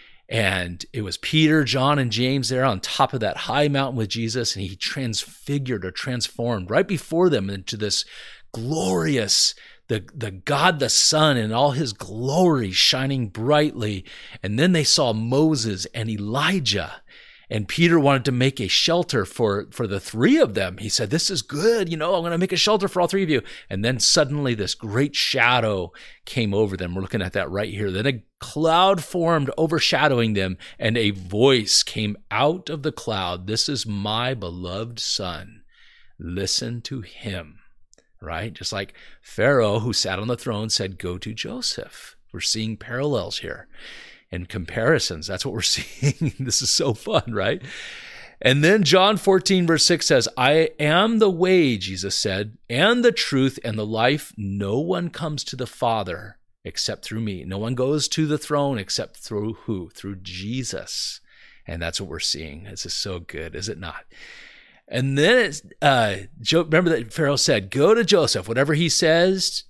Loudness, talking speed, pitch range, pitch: -21 LUFS, 180 wpm, 105-155 Hz, 125 Hz